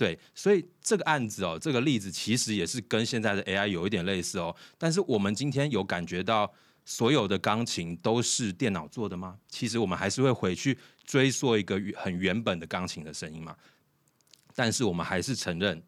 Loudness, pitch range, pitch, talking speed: -29 LUFS, 95-135 Hz, 110 Hz, 305 characters per minute